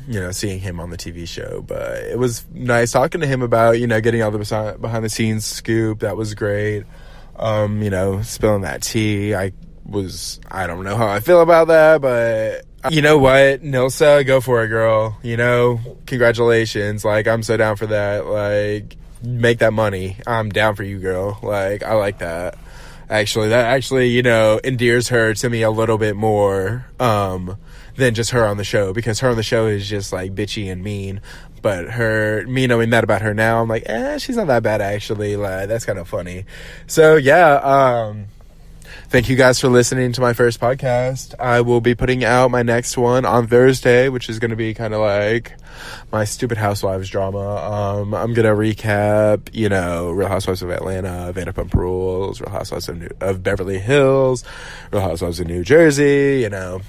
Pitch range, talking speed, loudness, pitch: 100-125 Hz, 195 wpm, -17 LUFS, 110 Hz